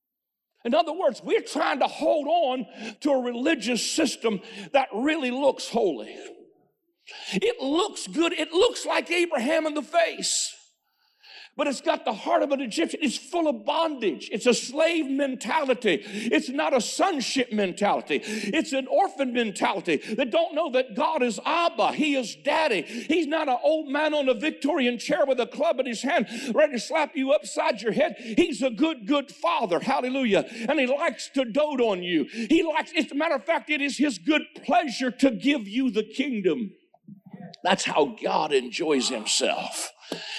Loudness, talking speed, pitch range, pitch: -25 LUFS, 175 wpm, 245-320 Hz, 285 Hz